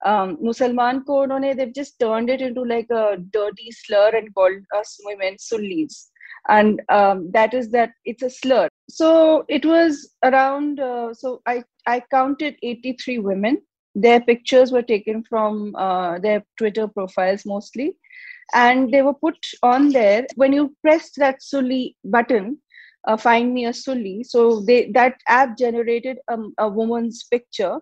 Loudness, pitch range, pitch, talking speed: -19 LUFS, 220-270 Hz, 240 Hz, 155 wpm